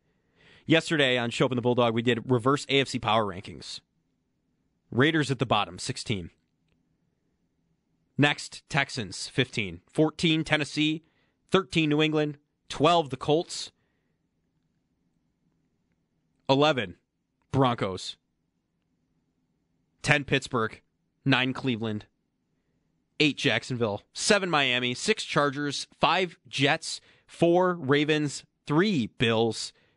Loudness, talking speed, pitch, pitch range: -26 LUFS, 90 wpm, 135 Hz, 115-150 Hz